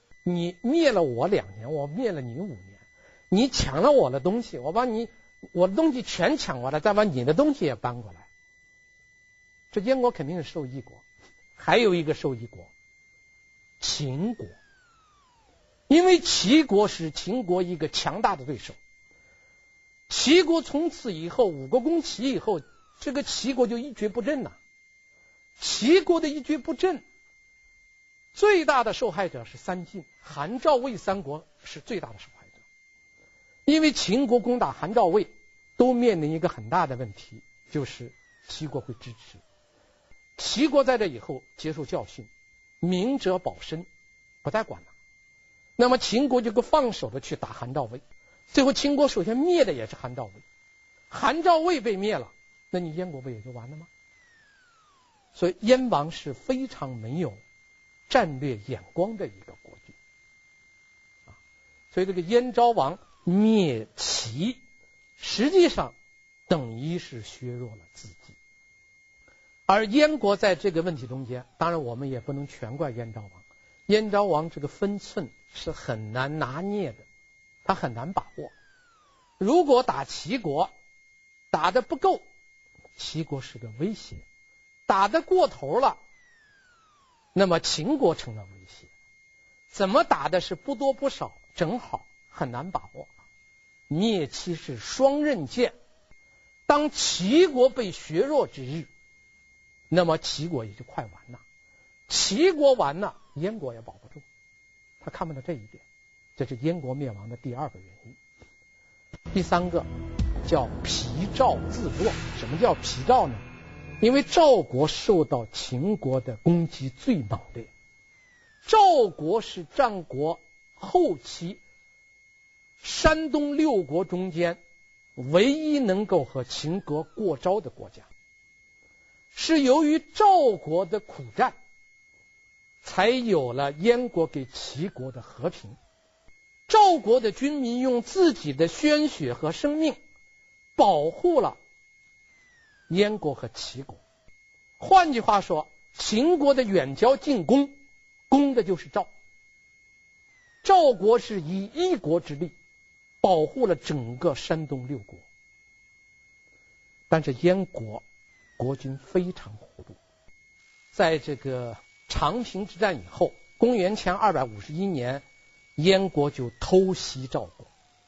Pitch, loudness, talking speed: 185 Hz, -25 LUFS, 195 characters per minute